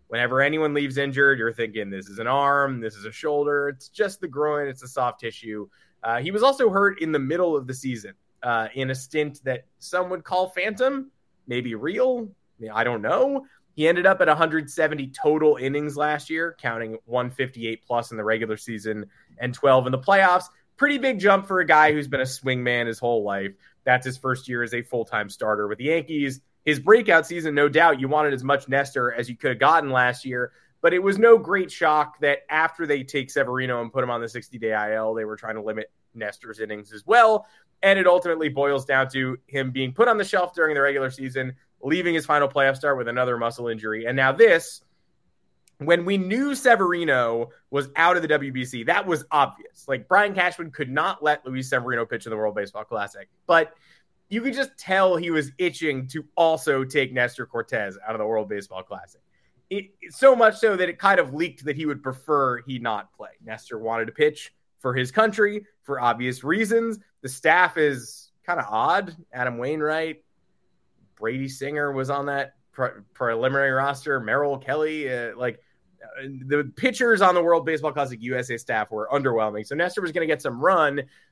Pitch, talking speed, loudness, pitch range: 140 Hz, 205 wpm, -23 LUFS, 120-170 Hz